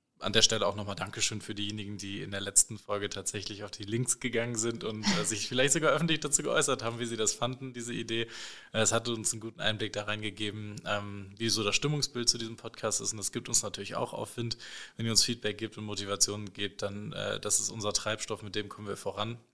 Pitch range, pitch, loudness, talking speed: 105-115 Hz, 110 Hz, -31 LUFS, 235 wpm